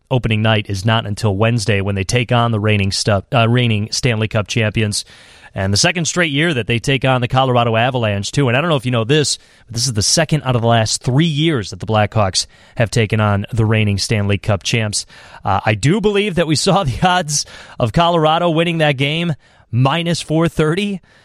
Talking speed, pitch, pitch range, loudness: 215 wpm, 120 Hz, 105-150 Hz, -16 LUFS